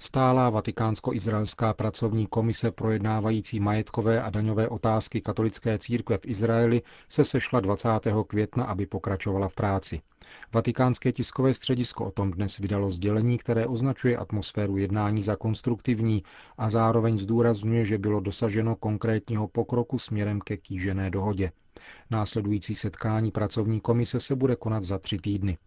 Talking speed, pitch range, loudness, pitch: 135 wpm, 105-115 Hz, -27 LUFS, 110 Hz